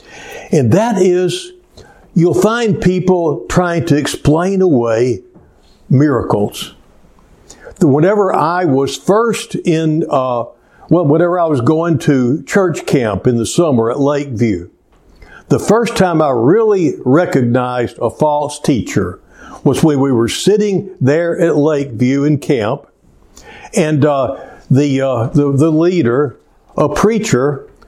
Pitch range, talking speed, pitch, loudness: 135-180 Hz, 125 wpm, 155 Hz, -13 LUFS